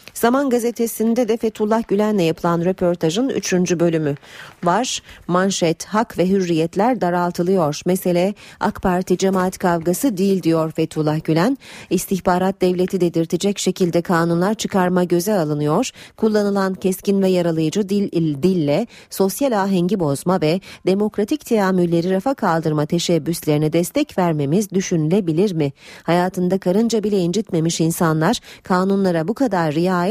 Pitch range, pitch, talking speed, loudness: 170-205 Hz, 185 Hz, 120 wpm, -19 LUFS